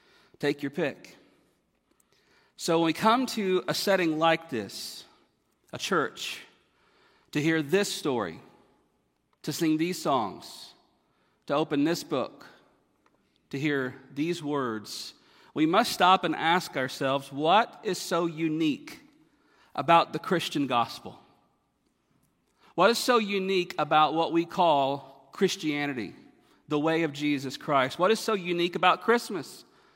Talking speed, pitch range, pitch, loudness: 130 wpm, 145-195 Hz, 165 Hz, -27 LUFS